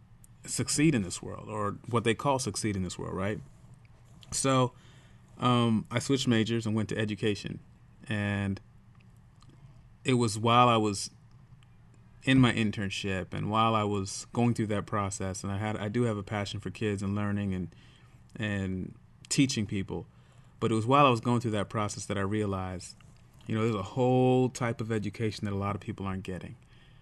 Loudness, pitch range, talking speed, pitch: -30 LUFS, 100-120 Hz, 185 wpm, 110 Hz